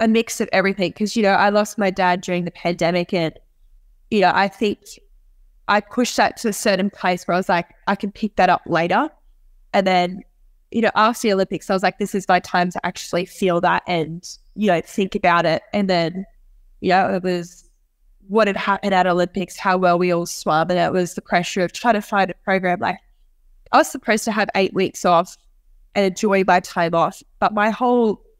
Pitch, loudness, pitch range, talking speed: 190 Hz, -19 LUFS, 175-210 Hz, 220 wpm